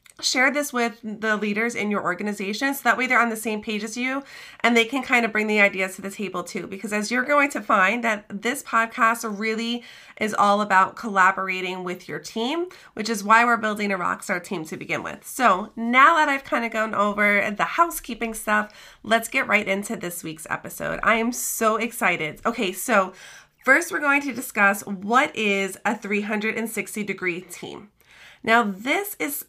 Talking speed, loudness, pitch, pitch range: 195 wpm, -22 LUFS, 220 Hz, 200-240 Hz